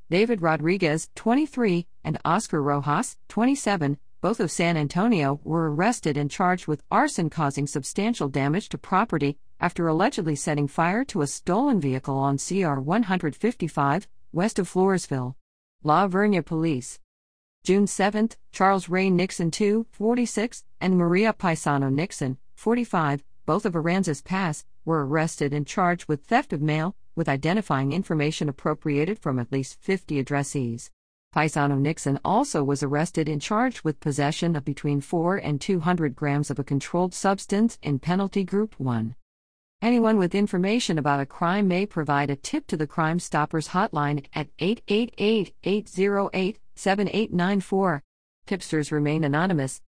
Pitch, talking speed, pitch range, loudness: 165 Hz, 140 wpm, 145-195 Hz, -25 LUFS